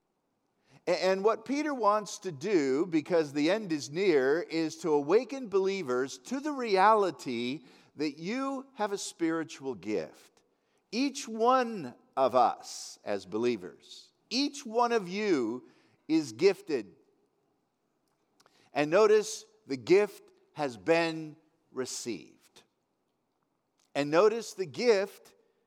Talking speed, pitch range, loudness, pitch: 110 wpm, 160-270 Hz, -30 LUFS, 210 Hz